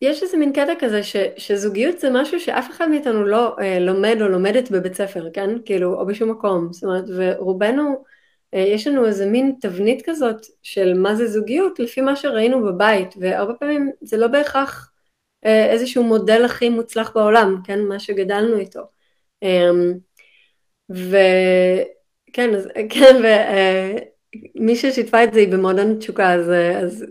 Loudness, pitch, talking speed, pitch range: -17 LUFS, 215 Hz, 155 wpm, 190-250 Hz